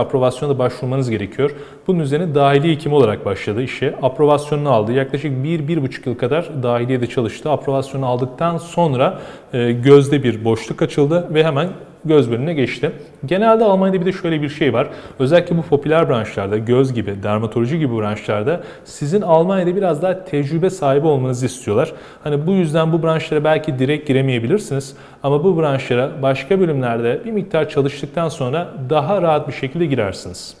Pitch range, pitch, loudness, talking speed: 130-165 Hz, 145 Hz, -17 LUFS, 155 wpm